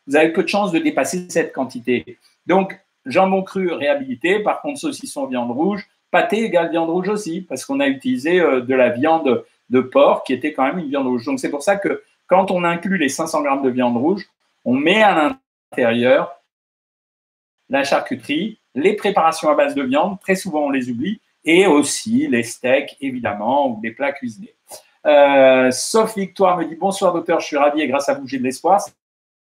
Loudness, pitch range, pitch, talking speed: -18 LUFS, 145-240 Hz, 180 Hz, 195 wpm